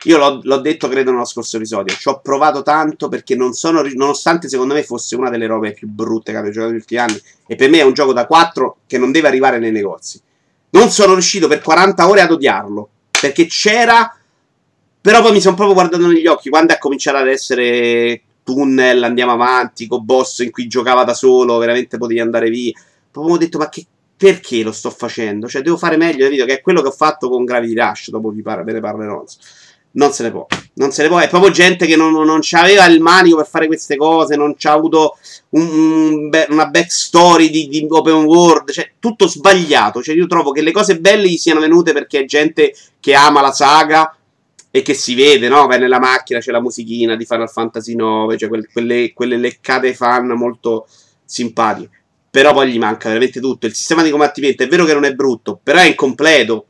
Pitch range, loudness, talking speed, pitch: 120-165 Hz, -12 LUFS, 215 wpm, 140 Hz